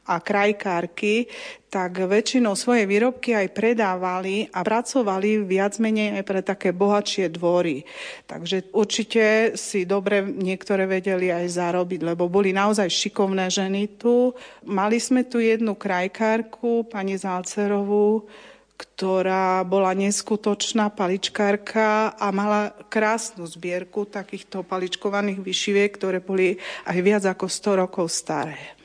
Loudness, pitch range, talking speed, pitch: -23 LUFS, 185-215 Hz, 120 wpm, 200 Hz